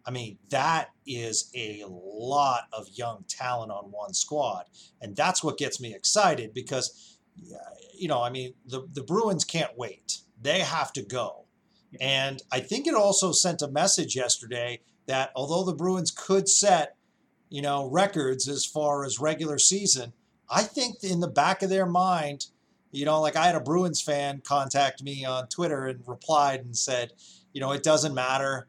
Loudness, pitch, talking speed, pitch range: -26 LUFS, 140 Hz, 175 wpm, 130-175 Hz